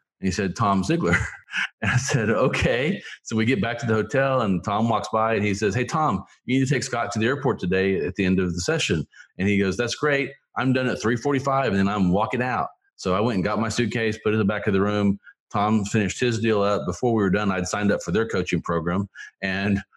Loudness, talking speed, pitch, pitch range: -23 LUFS, 260 wpm, 105 Hz, 95-120 Hz